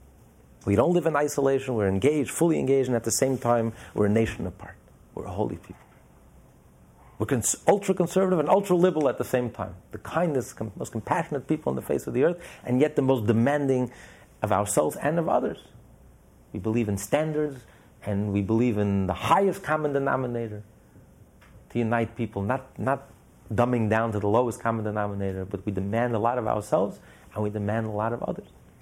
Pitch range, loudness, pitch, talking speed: 105-135 Hz, -26 LUFS, 115 Hz, 190 wpm